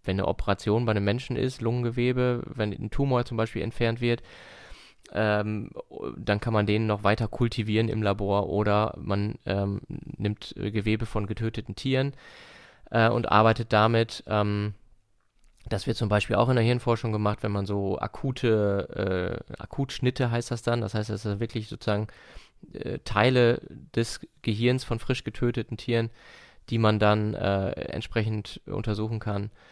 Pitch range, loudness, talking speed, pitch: 105-120 Hz, -27 LUFS, 155 wpm, 110 Hz